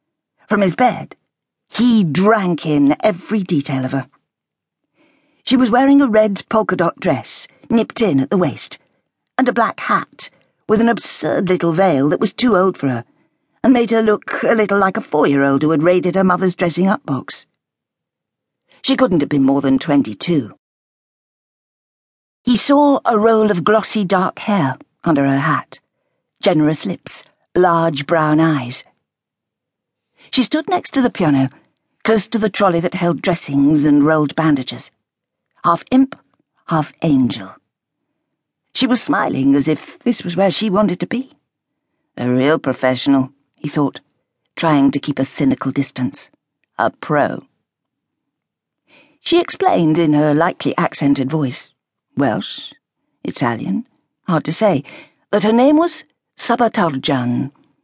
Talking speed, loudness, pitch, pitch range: 150 wpm, -16 LUFS, 170 Hz, 140-220 Hz